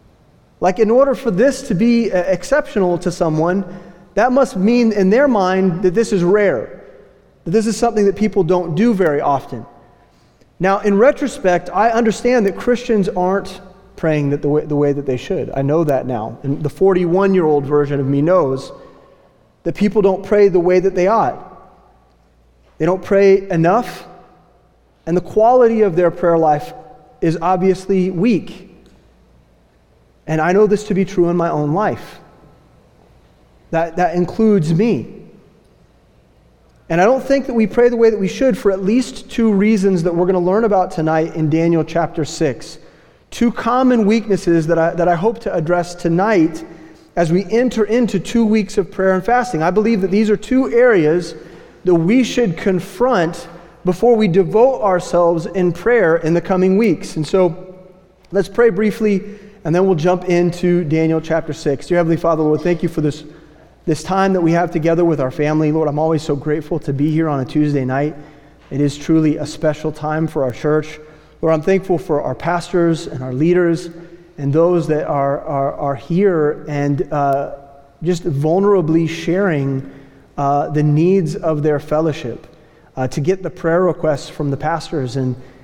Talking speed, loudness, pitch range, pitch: 175 wpm, -16 LUFS, 155-195 Hz, 175 Hz